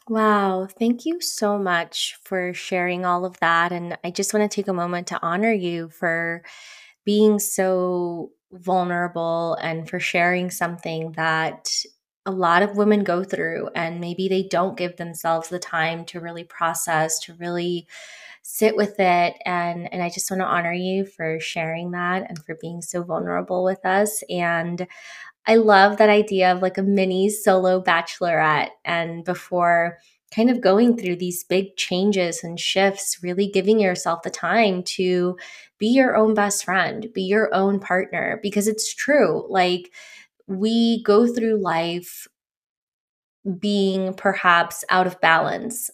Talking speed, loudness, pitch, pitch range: 155 wpm, -21 LUFS, 180 Hz, 170-205 Hz